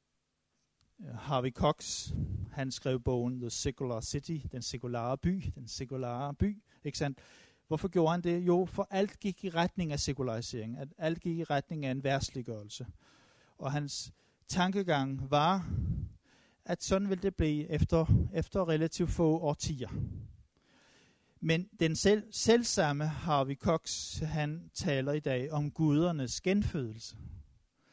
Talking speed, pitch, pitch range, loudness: 135 wpm, 145 Hz, 130-170 Hz, -33 LUFS